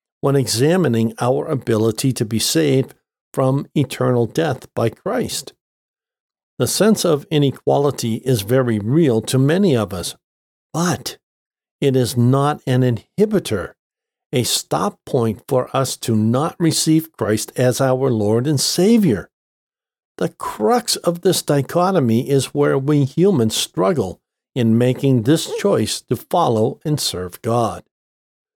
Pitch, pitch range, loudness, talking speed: 130 Hz, 115-155 Hz, -18 LUFS, 130 wpm